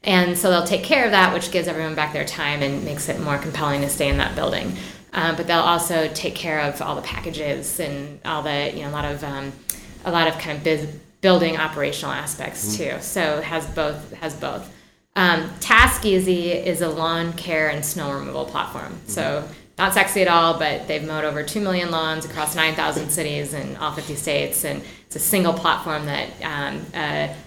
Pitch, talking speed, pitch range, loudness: 155 Hz, 210 wpm, 150-170 Hz, -21 LUFS